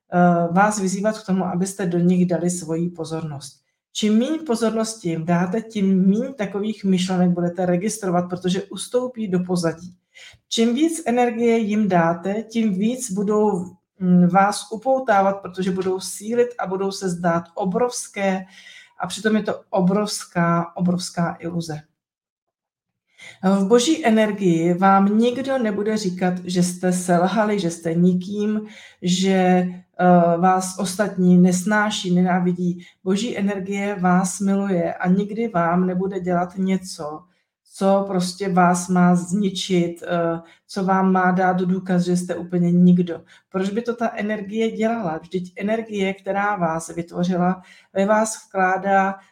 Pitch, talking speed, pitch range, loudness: 190 Hz, 130 wpm, 180-210 Hz, -20 LUFS